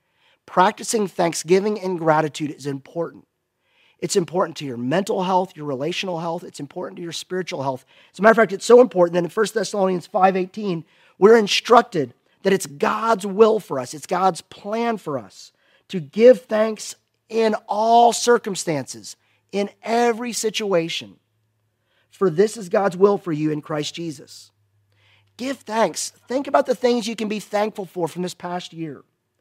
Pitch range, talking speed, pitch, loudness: 150-220 Hz, 165 wpm, 185 Hz, -20 LUFS